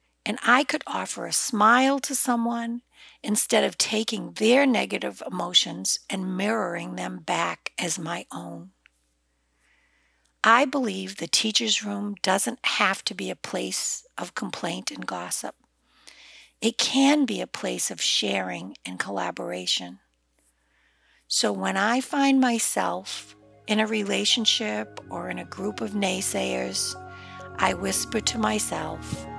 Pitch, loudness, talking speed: 205 Hz, -25 LUFS, 130 wpm